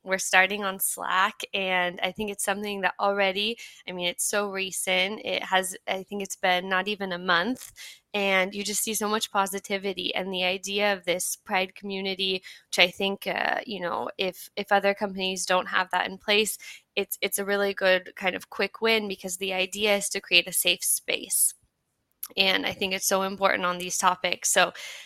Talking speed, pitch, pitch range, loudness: 200 wpm, 195 Hz, 185-200 Hz, -25 LUFS